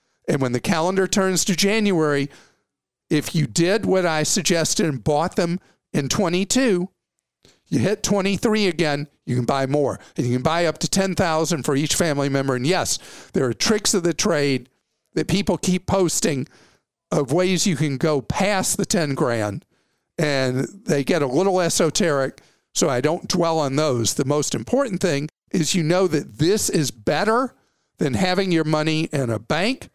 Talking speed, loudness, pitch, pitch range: 175 wpm, -21 LUFS, 165 Hz, 145-190 Hz